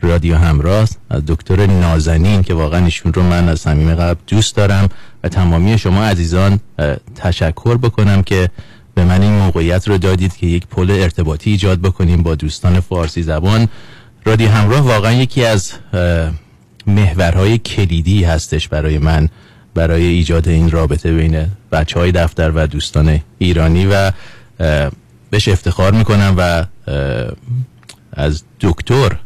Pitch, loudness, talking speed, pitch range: 90 Hz, -14 LUFS, 135 wpm, 80-100 Hz